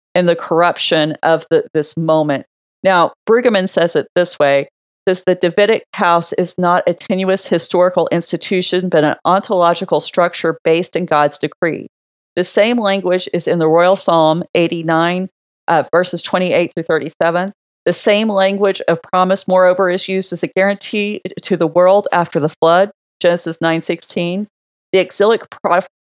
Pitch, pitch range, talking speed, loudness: 180 Hz, 165-190 Hz, 155 wpm, -15 LUFS